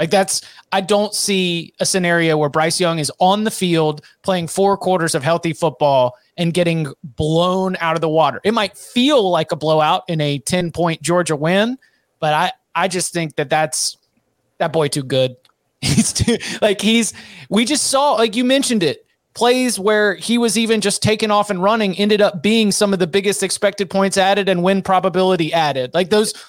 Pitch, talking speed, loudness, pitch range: 185 Hz, 195 wpm, -17 LUFS, 165-205 Hz